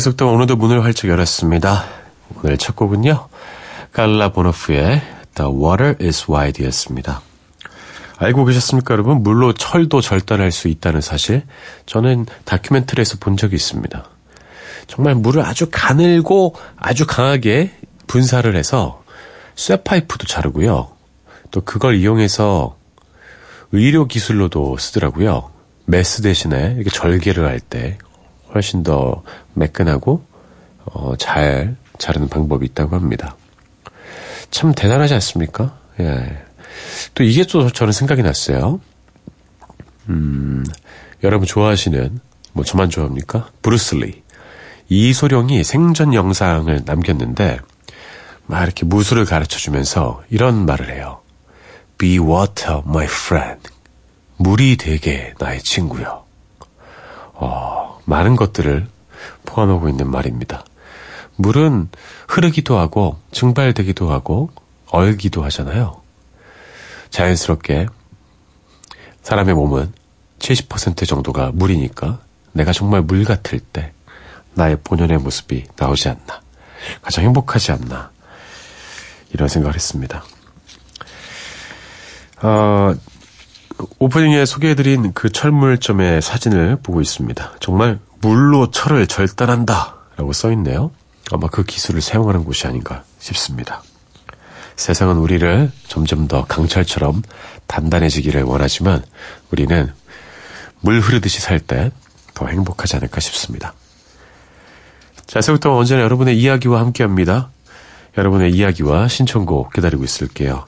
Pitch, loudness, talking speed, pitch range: 95 Hz, -16 LUFS, 270 characters per minute, 80-120 Hz